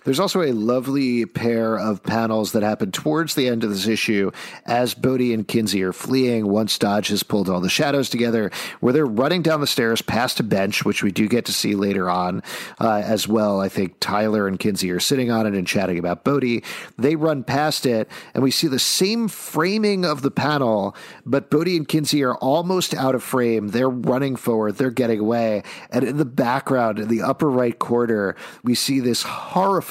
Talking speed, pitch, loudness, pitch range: 205 wpm, 120 Hz, -20 LUFS, 105-140 Hz